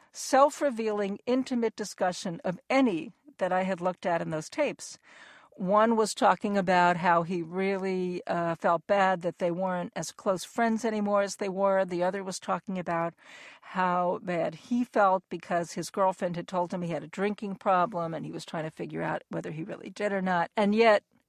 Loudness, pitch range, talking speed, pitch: -28 LUFS, 175-210 Hz, 195 wpm, 190 Hz